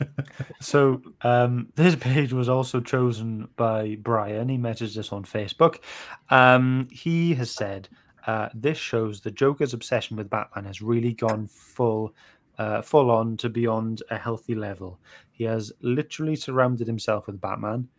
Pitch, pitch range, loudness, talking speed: 115 Hz, 110-130 Hz, -25 LUFS, 150 wpm